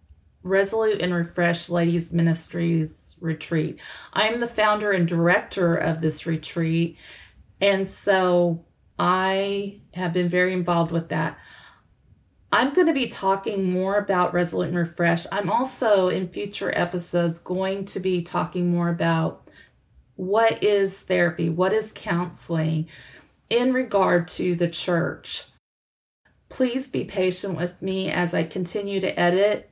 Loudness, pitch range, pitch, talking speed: -23 LUFS, 170-195 Hz, 180 Hz, 130 wpm